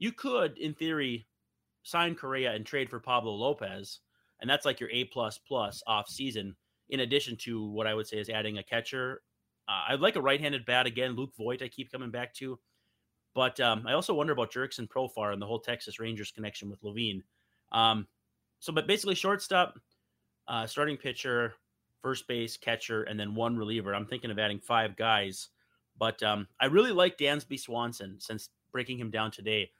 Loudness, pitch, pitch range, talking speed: -31 LUFS, 115 Hz, 105-130 Hz, 190 wpm